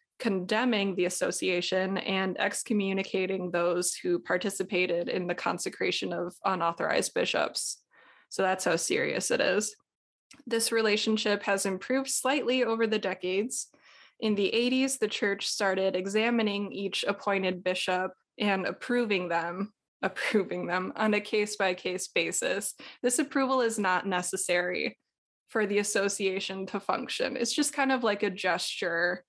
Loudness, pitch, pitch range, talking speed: -29 LUFS, 200 Hz, 185-225 Hz, 135 wpm